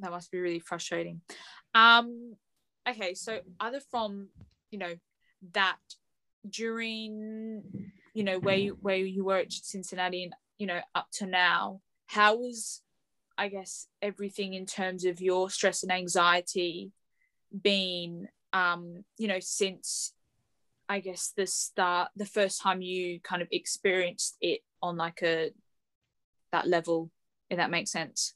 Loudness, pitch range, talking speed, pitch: -30 LUFS, 180-205 Hz, 140 wpm, 190 Hz